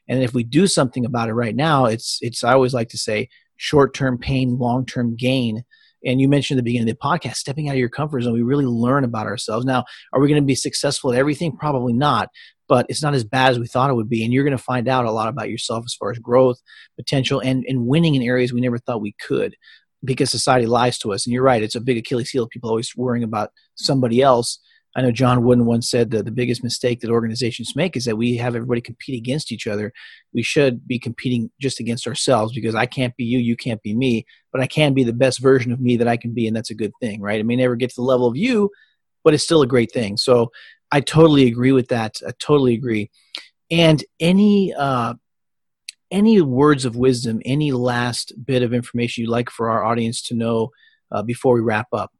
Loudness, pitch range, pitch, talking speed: -19 LUFS, 115-135 Hz, 125 Hz, 245 wpm